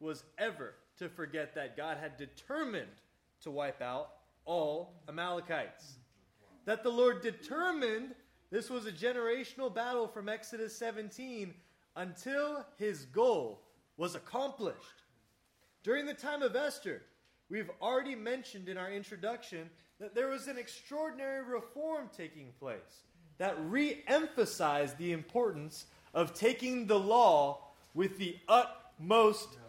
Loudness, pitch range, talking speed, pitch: -36 LUFS, 170-255 Hz, 125 wpm, 225 Hz